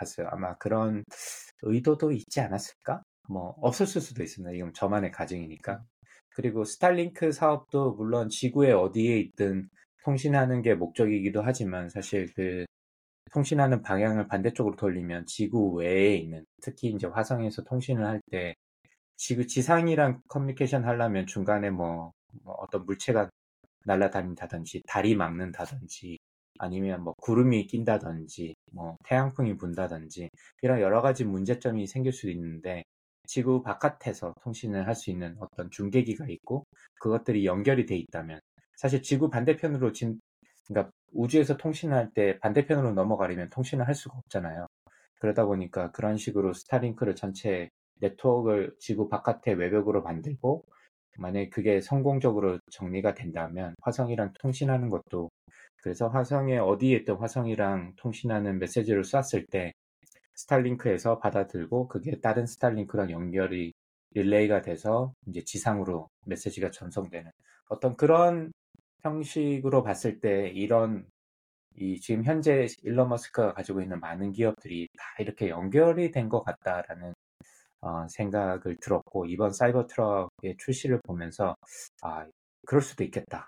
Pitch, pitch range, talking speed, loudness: 105 Hz, 90-125 Hz, 330 characters per minute, -29 LUFS